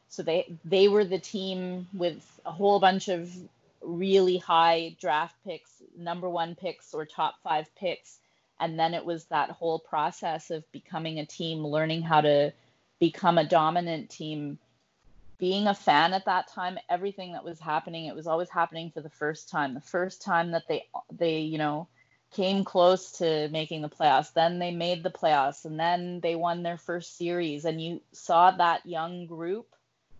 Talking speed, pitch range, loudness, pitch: 180 wpm, 160-180 Hz, -28 LUFS, 170 Hz